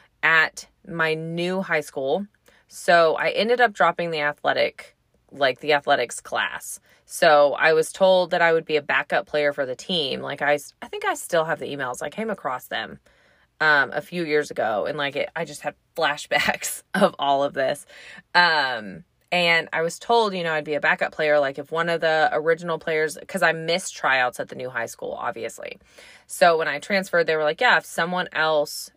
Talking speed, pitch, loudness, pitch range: 205 wpm, 160 Hz, -22 LUFS, 145-170 Hz